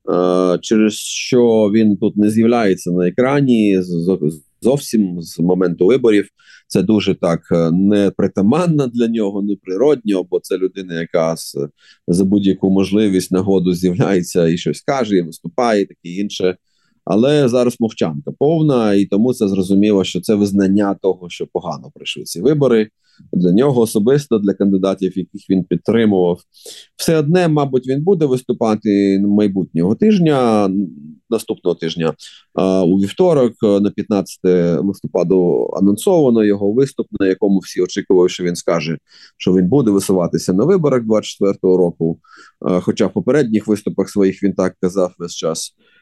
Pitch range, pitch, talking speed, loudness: 90-110 Hz, 100 Hz, 140 wpm, -16 LUFS